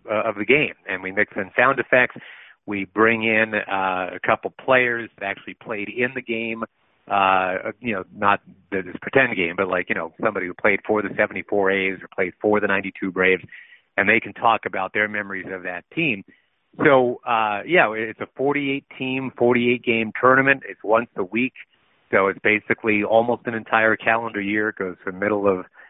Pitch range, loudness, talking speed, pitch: 95-120 Hz, -21 LUFS, 195 wpm, 105 Hz